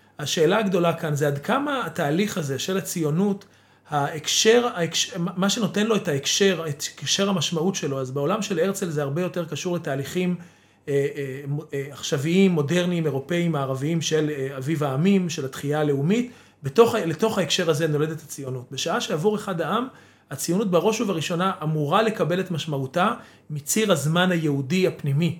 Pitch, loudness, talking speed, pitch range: 165 Hz, -23 LUFS, 155 wpm, 145-190 Hz